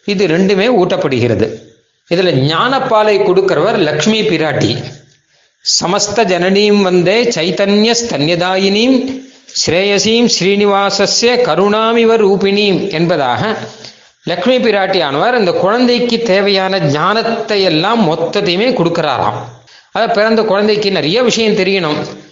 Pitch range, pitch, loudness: 180-220 Hz, 200 Hz, -12 LUFS